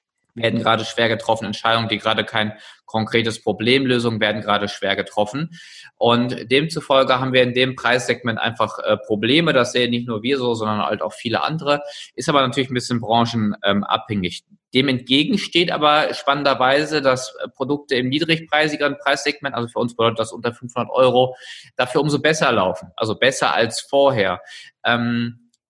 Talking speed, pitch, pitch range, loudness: 160 wpm, 125 Hz, 115-140 Hz, -19 LUFS